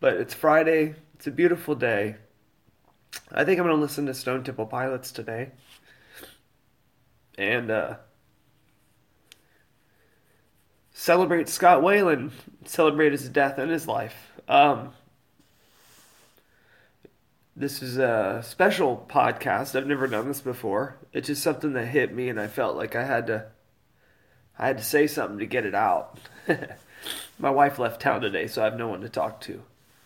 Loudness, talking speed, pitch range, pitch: -25 LUFS, 150 wpm, 120-155 Hz, 135 Hz